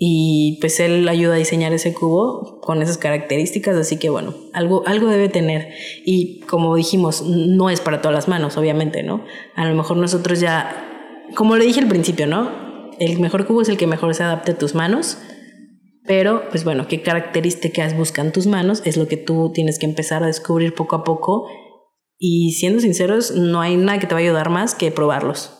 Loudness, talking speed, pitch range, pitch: -18 LUFS, 200 wpm, 160-185 Hz, 170 Hz